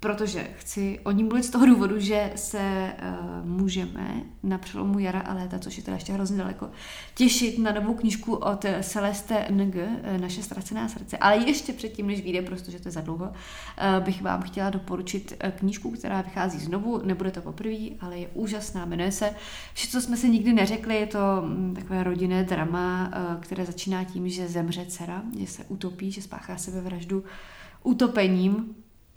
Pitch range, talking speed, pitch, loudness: 185-210 Hz, 175 wpm, 195 Hz, -27 LUFS